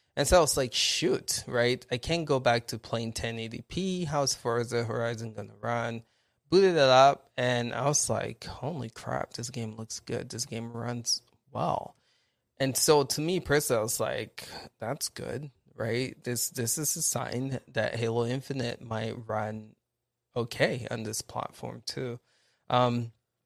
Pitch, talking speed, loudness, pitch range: 120 Hz, 170 wpm, -29 LUFS, 115-135 Hz